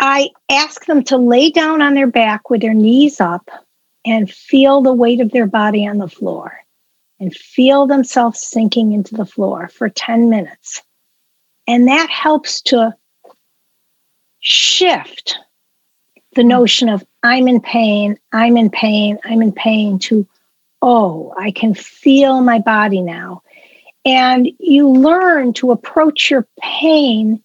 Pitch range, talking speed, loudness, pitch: 215-275 Hz, 140 wpm, -12 LUFS, 240 Hz